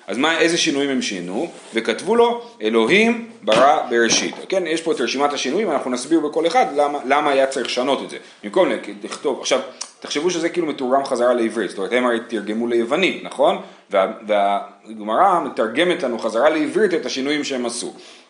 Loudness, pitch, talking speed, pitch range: -19 LUFS, 140 Hz, 175 wpm, 115-165 Hz